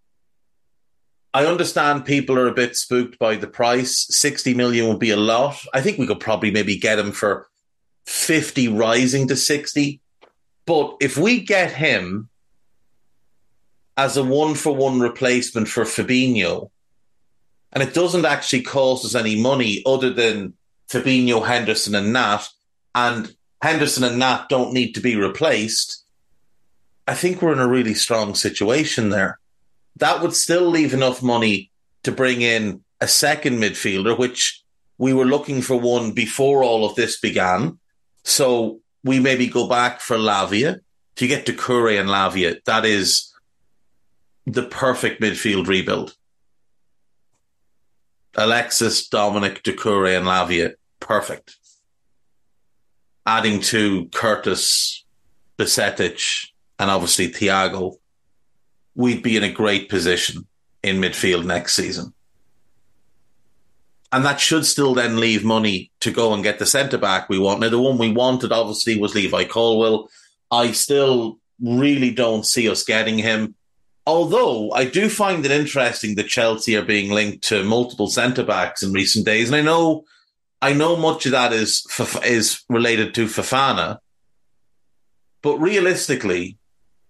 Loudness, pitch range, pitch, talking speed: -19 LUFS, 105-130 Hz, 115 Hz, 140 wpm